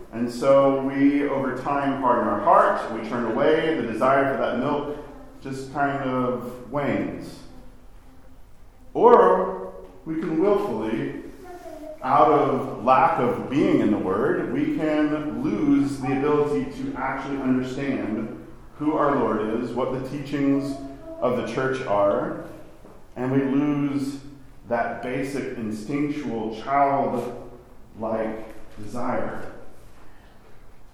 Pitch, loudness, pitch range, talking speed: 135 Hz, -23 LUFS, 120-145 Hz, 115 wpm